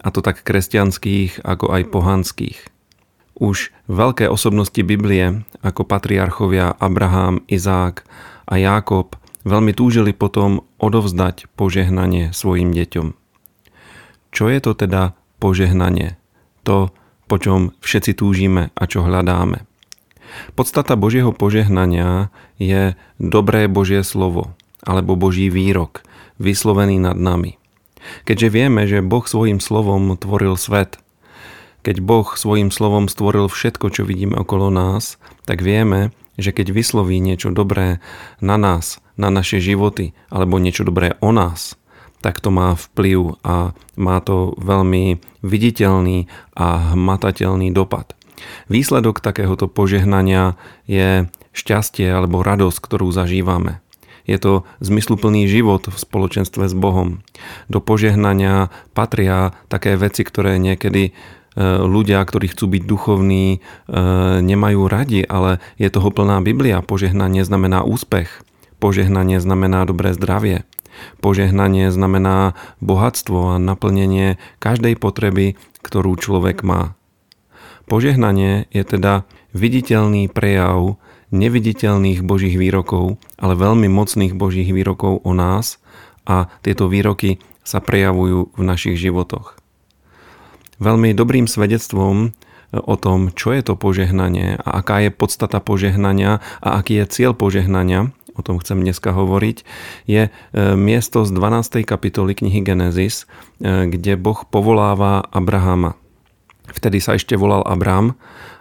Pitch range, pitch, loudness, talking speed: 95-105 Hz, 95 Hz, -16 LUFS, 120 wpm